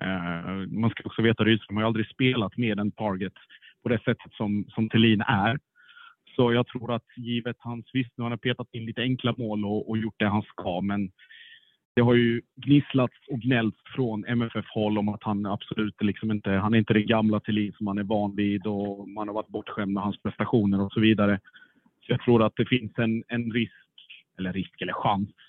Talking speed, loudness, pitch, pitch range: 215 wpm, -27 LUFS, 110 Hz, 105-120 Hz